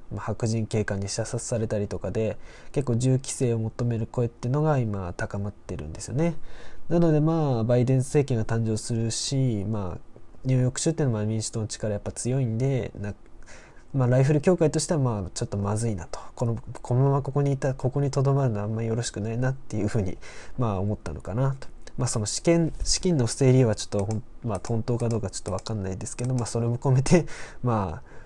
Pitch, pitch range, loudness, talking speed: 115 Hz, 105-130 Hz, -26 LUFS, 435 characters per minute